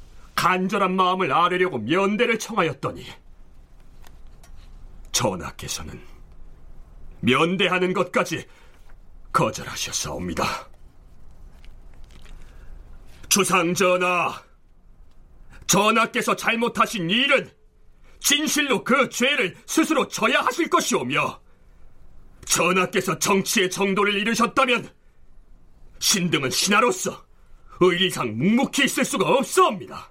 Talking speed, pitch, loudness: 210 characters per minute, 185 Hz, -21 LUFS